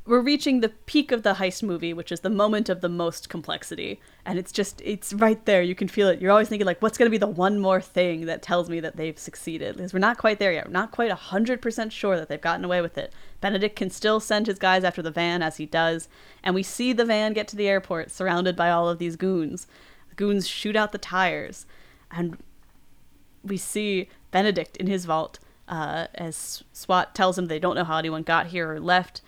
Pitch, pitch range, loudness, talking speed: 185 Hz, 170-210 Hz, -25 LUFS, 235 wpm